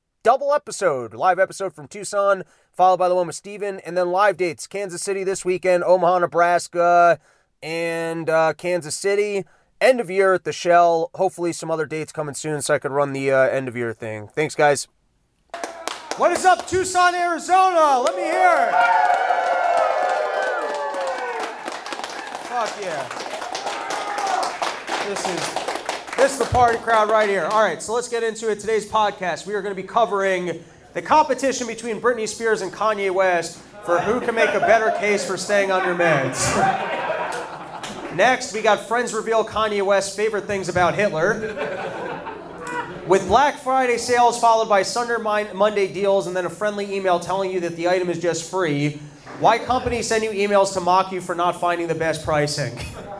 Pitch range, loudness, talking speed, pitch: 170-220 Hz, -20 LUFS, 170 wpm, 195 Hz